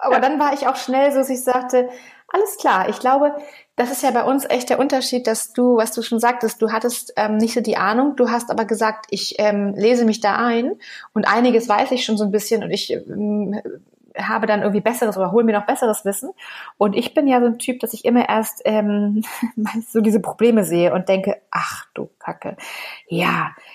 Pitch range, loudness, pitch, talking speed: 215-255 Hz, -19 LUFS, 230 Hz, 220 wpm